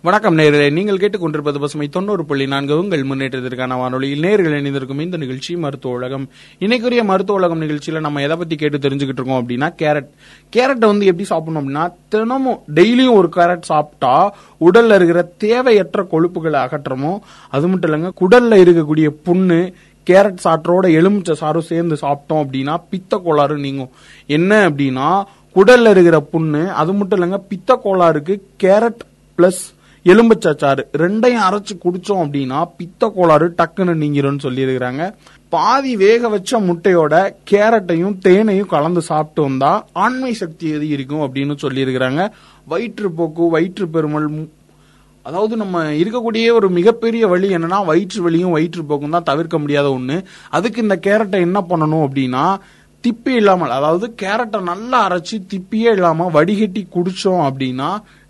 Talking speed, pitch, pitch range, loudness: 130 wpm, 175 Hz, 150-200 Hz, -15 LUFS